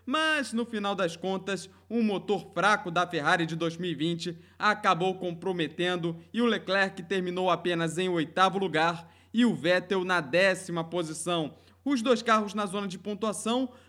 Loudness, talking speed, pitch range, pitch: -28 LUFS, 150 wpm, 175-210 Hz, 185 Hz